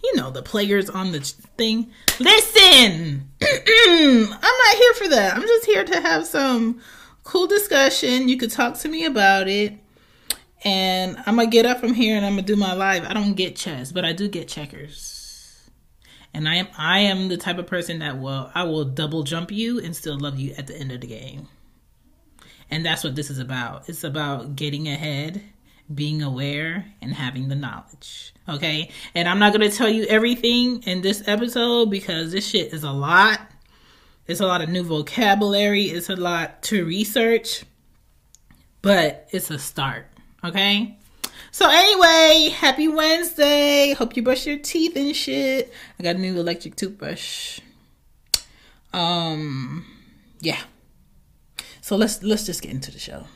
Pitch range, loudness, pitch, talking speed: 155-235 Hz, -19 LUFS, 190 Hz, 175 wpm